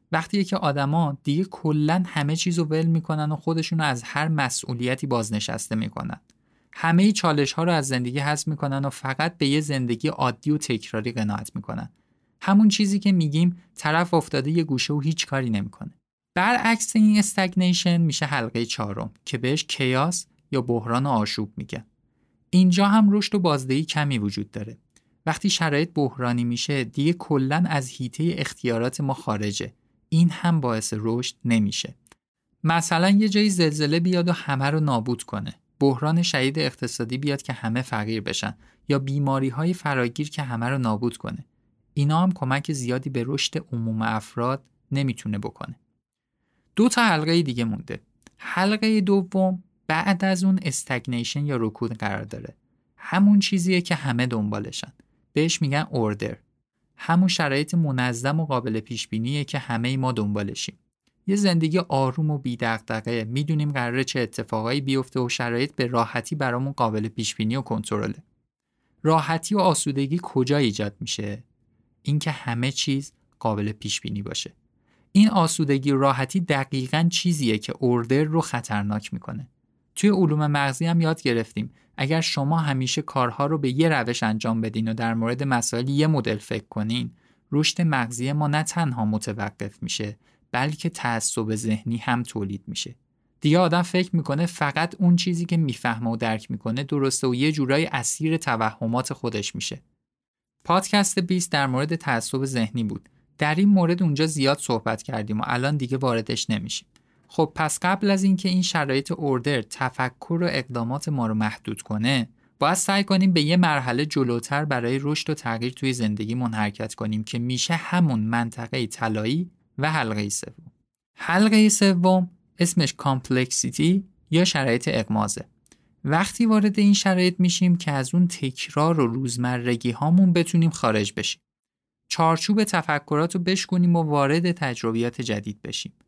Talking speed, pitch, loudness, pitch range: 150 wpm, 140 Hz, -23 LUFS, 120-165 Hz